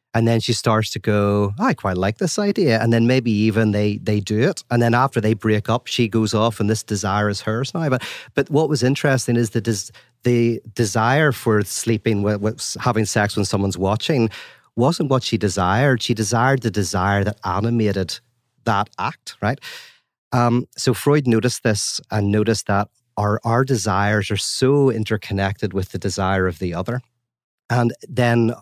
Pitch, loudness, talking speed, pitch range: 115 Hz, -20 LUFS, 185 wpm, 105-120 Hz